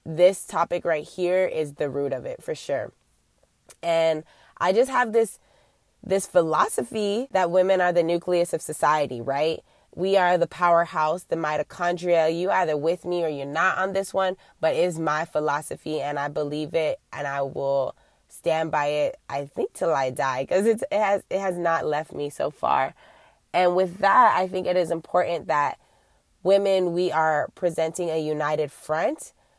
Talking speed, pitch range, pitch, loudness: 175 wpm, 150-185 Hz, 170 Hz, -24 LUFS